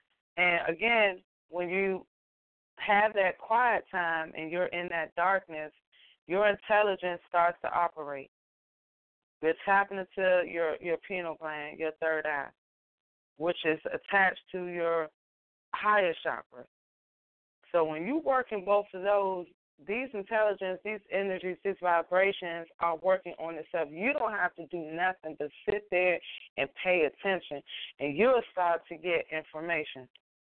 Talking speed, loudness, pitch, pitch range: 140 wpm, -30 LUFS, 175 Hz, 160-195 Hz